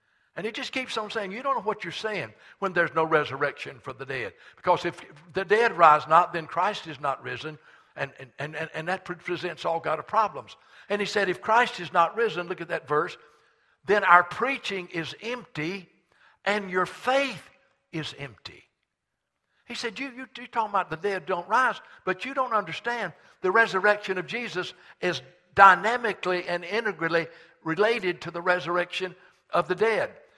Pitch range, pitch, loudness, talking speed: 165-220 Hz, 180 Hz, -26 LUFS, 180 wpm